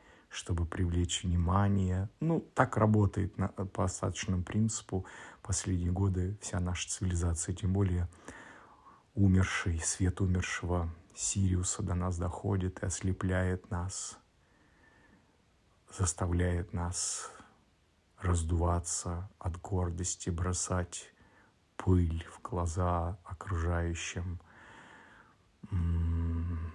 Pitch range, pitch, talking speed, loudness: 85-95 Hz, 90 Hz, 80 wpm, -33 LUFS